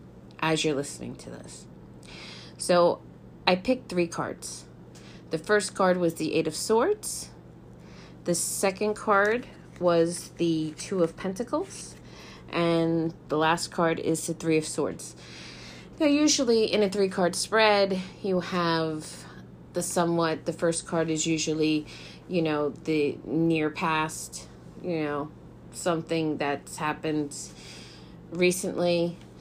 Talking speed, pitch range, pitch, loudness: 125 wpm, 145-180 Hz, 165 Hz, -27 LUFS